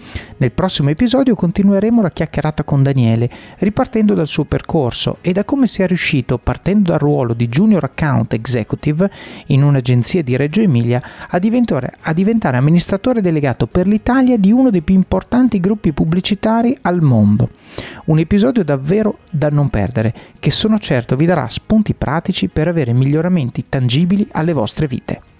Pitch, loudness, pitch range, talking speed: 165 Hz, -15 LUFS, 135-205 Hz, 155 wpm